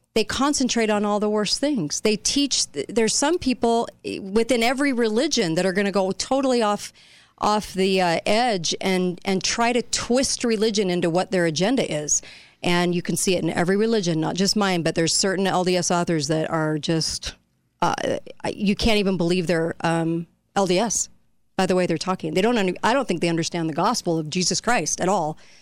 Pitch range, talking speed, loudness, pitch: 175-225 Hz, 195 wpm, -22 LUFS, 190 Hz